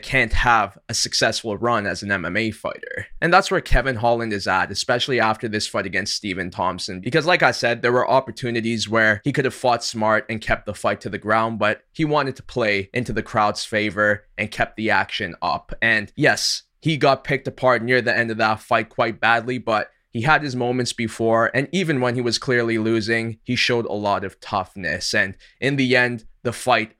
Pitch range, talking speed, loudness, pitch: 110-125 Hz, 215 wpm, -21 LUFS, 115 Hz